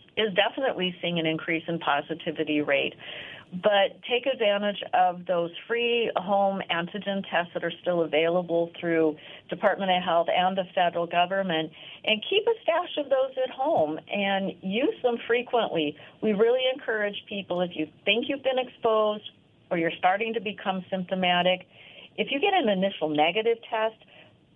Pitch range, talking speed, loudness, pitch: 170-225 Hz, 155 wpm, -26 LUFS, 190 Hz